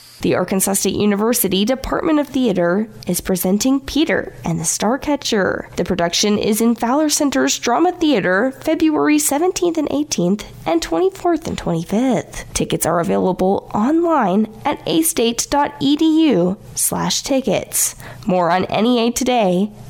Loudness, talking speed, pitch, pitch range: -17 LUFS, 125 wpm, 235 Hz, 190-295 Hz